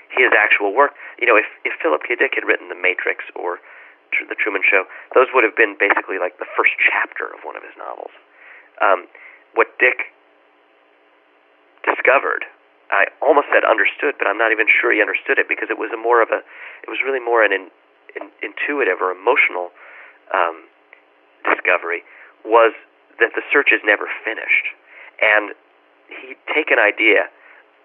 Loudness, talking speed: -17 LUFS, 170 wpm